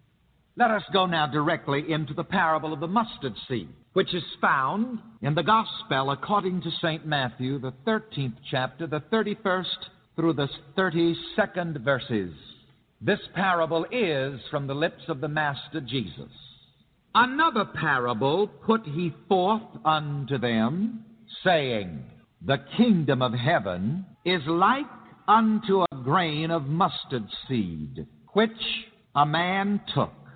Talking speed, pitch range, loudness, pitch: 130 wpm, 145-205 Hz, -26 LUFS, 170 Hz